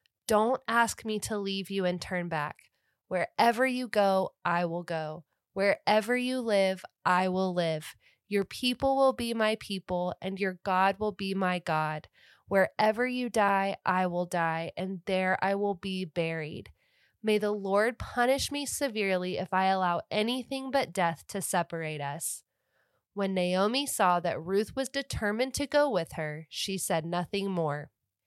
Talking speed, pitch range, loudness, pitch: 160 wpm, 175-215 Hz, -29 LUFS, 195 Hz